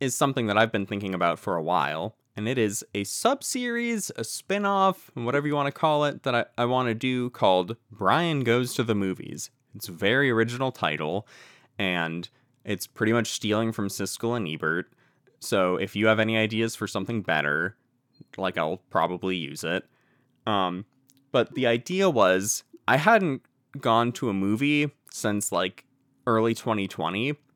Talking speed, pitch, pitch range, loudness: 170 wpm, 115 Hz, 100-135 Hz, -26 LUFS